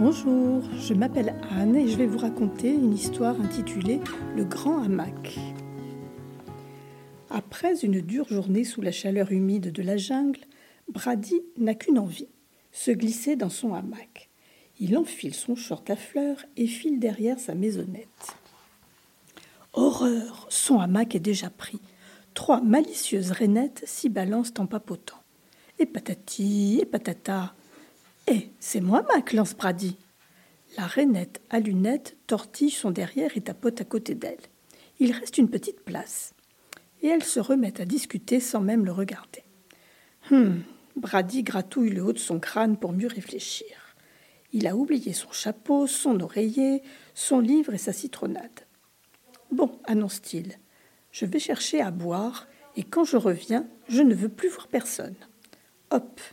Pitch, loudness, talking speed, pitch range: 225 Hz, -26 LUFS, 145 wpm, 195-270 Hz